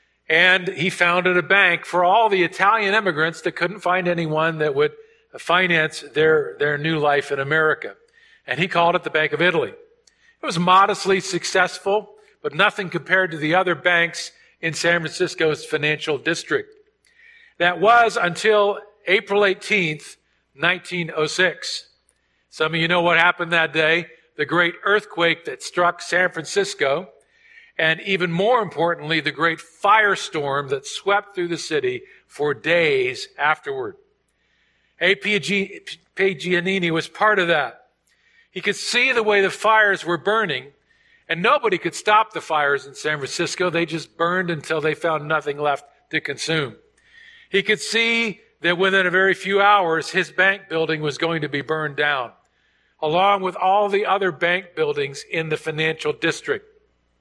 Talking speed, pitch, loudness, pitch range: 150 wpm, 180 Hz, -20 LUFS, 165-210 Hz